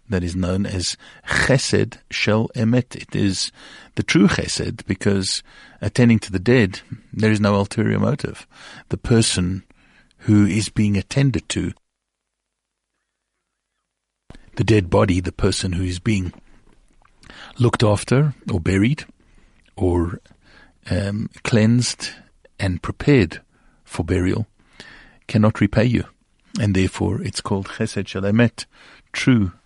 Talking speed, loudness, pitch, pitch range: 120 wpm, -20 LUFS, 105 Hz, 95-115 Hz